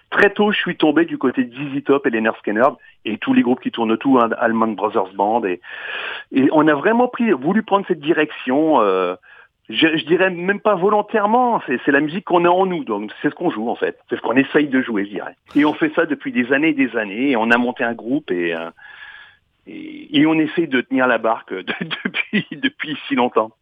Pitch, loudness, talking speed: 185 Hz, -18 LUFS, 240 wpm